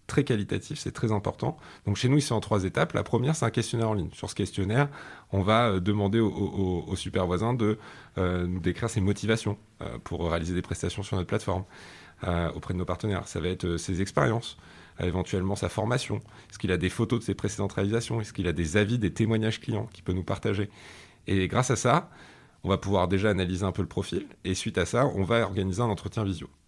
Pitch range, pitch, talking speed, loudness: 90-110 Hz, 100 Hz, 220 wpm, -28 LUFS